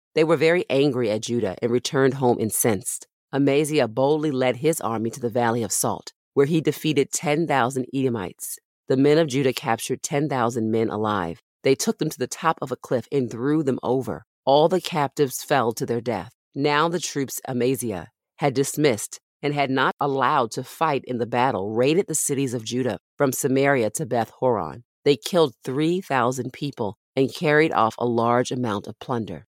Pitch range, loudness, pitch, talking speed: 120-150 Hz, -23 LUFS, 135 Hz, 190 wpm